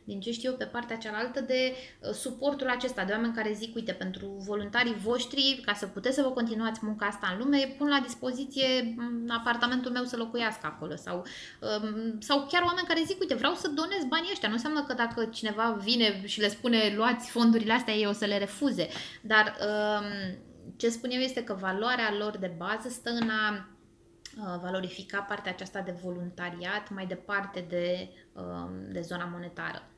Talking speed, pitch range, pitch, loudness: 180 wpm, 200-250 Hz, 225 Hz, -30 LUFS